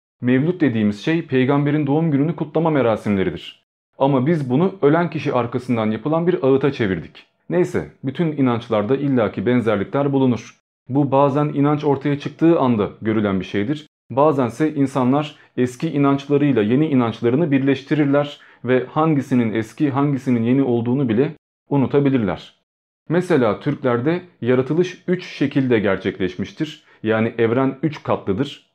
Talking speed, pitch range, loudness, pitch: 120 wpm, 120-150 Hz, -19 LUFS, 140 Hz